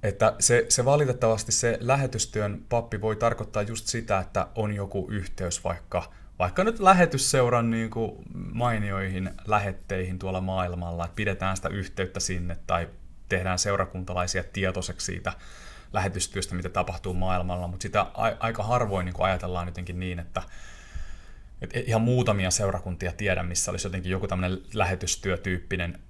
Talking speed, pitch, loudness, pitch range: 135 wpm, 95 Hz, -27 LUFS, 90-110 Hz